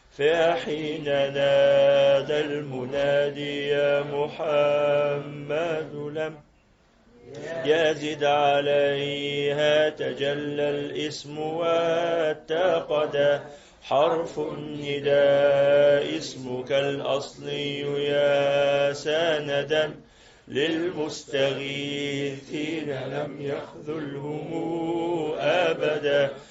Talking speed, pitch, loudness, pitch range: 50 wpm, 145 Hz, -25 LUFS, 140-155 Hz